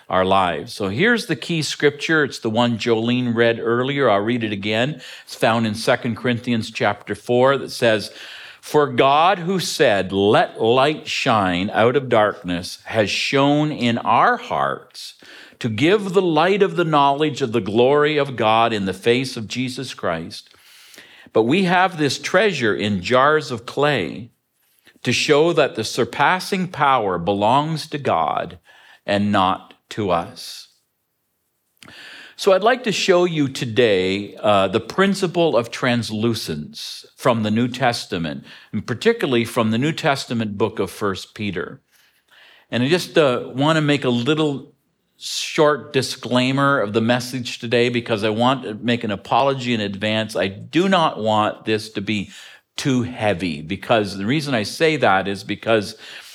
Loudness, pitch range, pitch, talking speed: -19 LUFS, 110-145 Hz, 120 Hz, 160 wpm